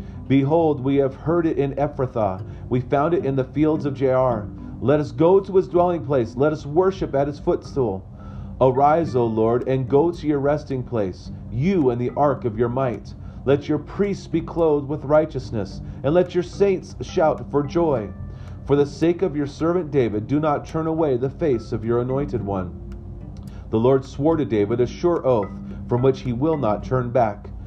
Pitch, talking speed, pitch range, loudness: 135 Hz, 195 wpm, 110-155 Hz, -21 LUFS